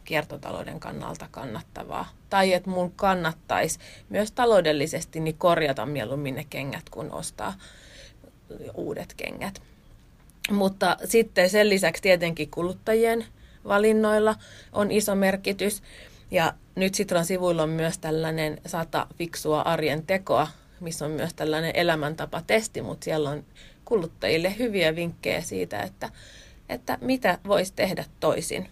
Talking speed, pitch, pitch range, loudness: 120 wpm, 175 Hz, 155-200 Hz, -26 LUFS